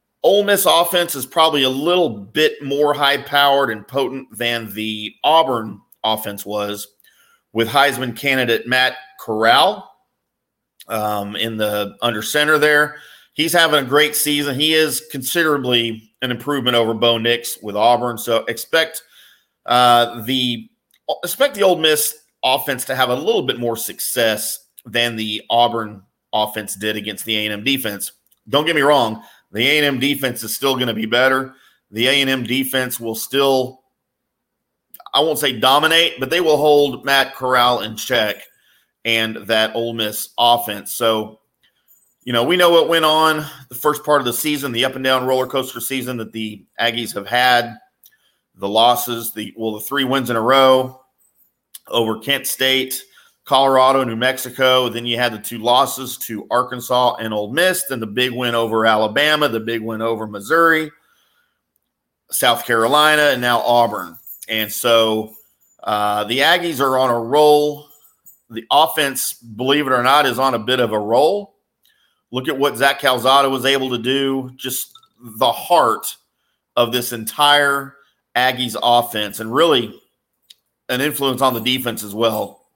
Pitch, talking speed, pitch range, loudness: 130 Hz, 160 wpm, 115-140 Hz, -17 LUFS